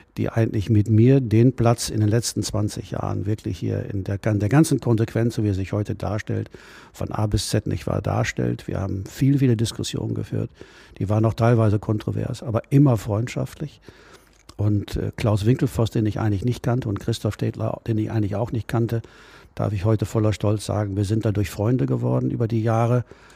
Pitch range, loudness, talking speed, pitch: 105-120 Hz, -23 LUFS, 195 wpm, 110 Hz